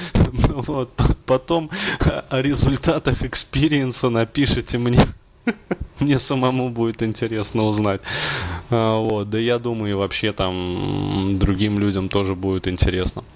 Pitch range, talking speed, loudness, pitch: 100-130 Hz, 110 wpm, -21 LUFS, 115 Hz